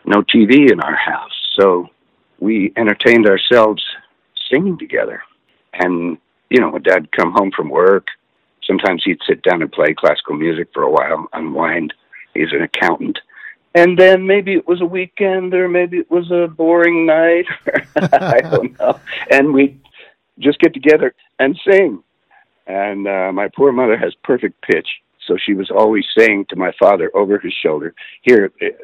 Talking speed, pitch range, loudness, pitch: 165 wpm, 140-200 Hz, -14 LUFS, 175 Hz